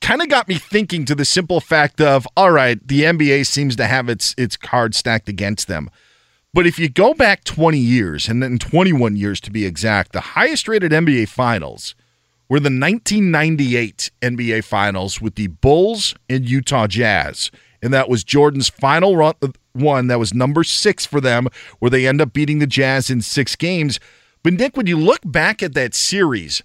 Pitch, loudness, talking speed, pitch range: 135 Hz, -16 LUFS, 200 wpm, 115-155 Hz